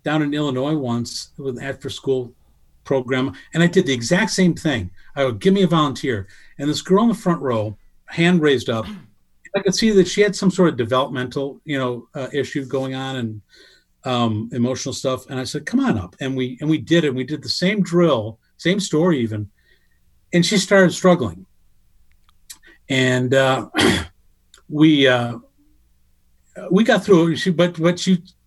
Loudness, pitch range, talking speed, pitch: -19 LUFS, 125-175 Hz, 180 wpm, 135 Hz